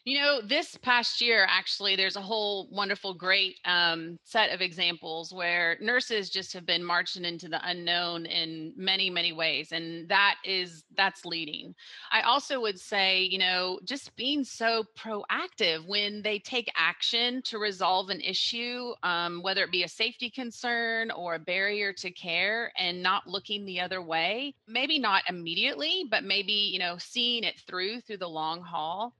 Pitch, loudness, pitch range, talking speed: 195 Hz, -28 LUFS, 175-225 Hz, 170 wpm